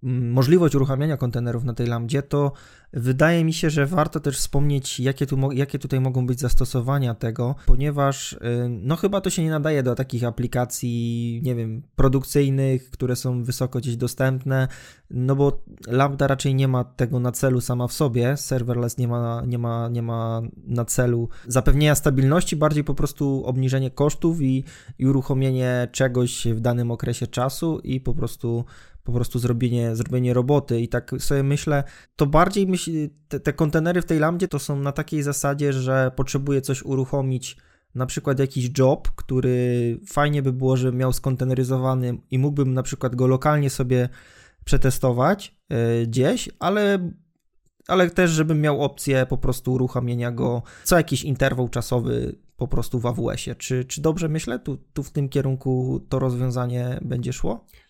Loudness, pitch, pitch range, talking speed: -23 LUFS, 130 Hz, 125-145 Hz, 165 wpm